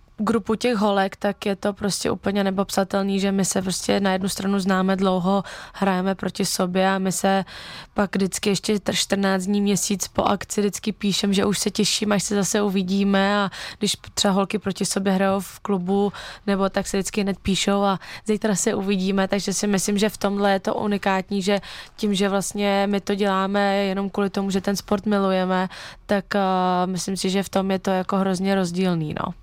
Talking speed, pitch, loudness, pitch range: 200 wpm, 195 Hz, -22 LUFS, 190-205 Hz